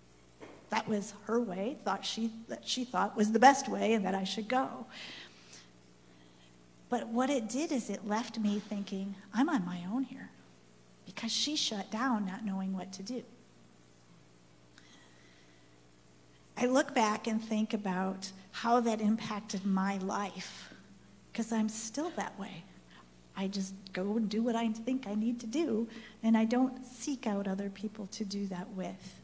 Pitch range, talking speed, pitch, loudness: 175-225 Hz, 165 wpm, 200 Hz, -34 LUFS